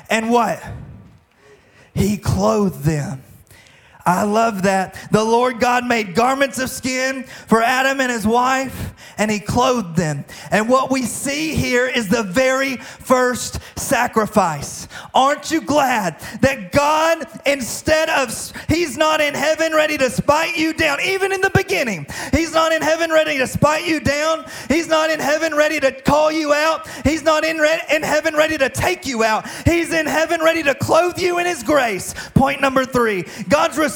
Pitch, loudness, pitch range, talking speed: 265 Hz, -17 LUFS, 220-310 Hz, 170 wpm